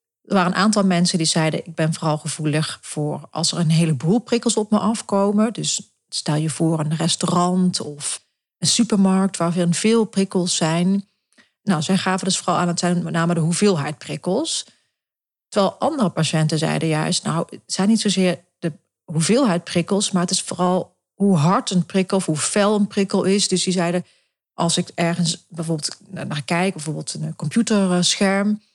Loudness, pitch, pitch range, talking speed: -20 LUFS, 180 Hz, 165-195 Hz, 175 wpm